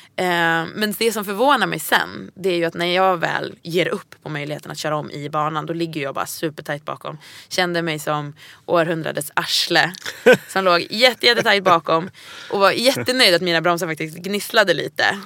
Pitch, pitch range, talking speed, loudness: 170 Hz, 160-195 Hz, 180 wpm, -19 LUFS